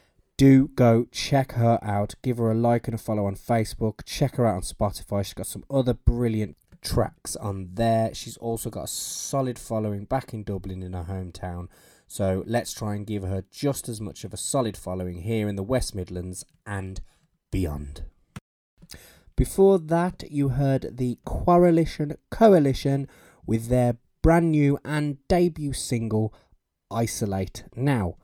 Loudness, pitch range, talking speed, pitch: -25 LUFS, 100-135 Hz, 160 wpm, 115 Hz